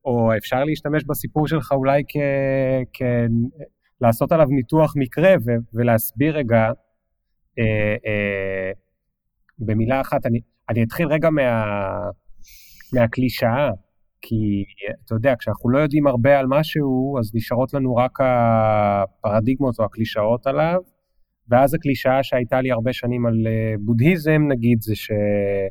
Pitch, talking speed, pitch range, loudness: 120 Hz, 120 wpm, 110-140 Hz, -20 LUFS